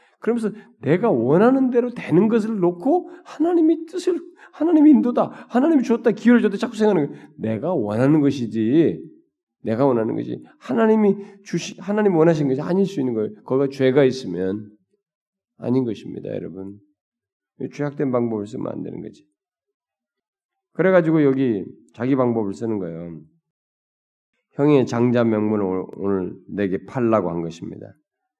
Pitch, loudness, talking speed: 160 Hz, -20 LUFS, 340 characters per minute